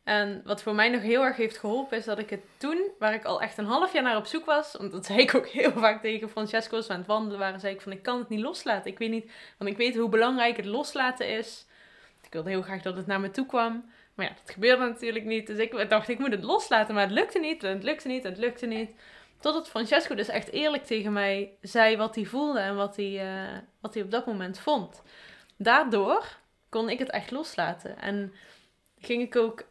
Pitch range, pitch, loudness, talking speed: 205-250 Hz, 225 Hz, -28 LUFS, 245 wpm